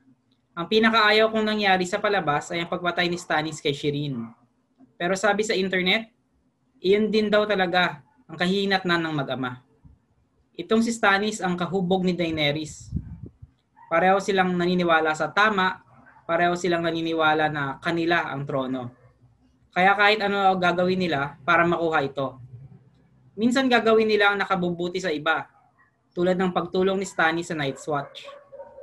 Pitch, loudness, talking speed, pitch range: 175 Hz, -23 LUFS, 140 wpm, 150-195 Hz